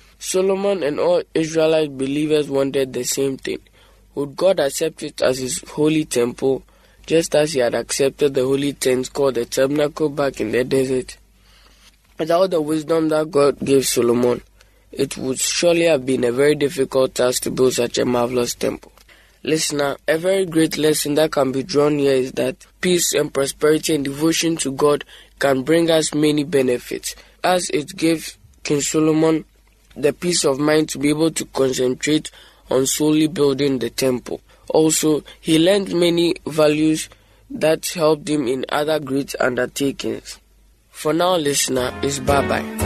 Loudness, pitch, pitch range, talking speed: -19 LUFS, 145 Hz, 130-155 Hz, 160 wpm